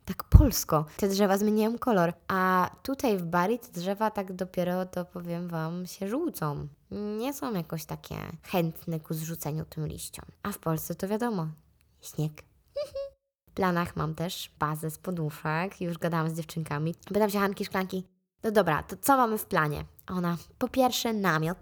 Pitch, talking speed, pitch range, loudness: 180 Hz, 165 wpm, 165-210 Hz, -29 LUFS